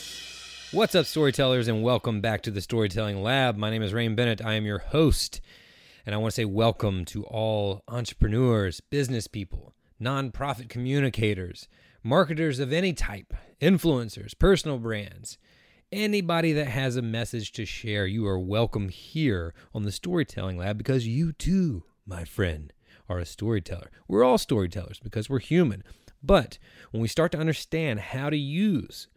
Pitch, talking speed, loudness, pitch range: 115 Hz, 160 wpm, -27 LUFS, 105-140 Hz